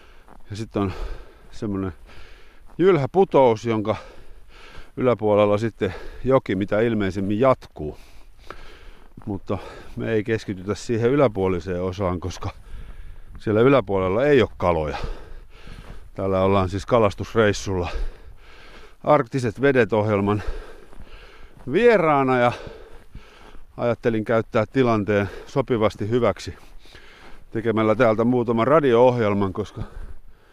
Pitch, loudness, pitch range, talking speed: 110 Hz, -21 LUFS, 100-125 Hz, 85 wpm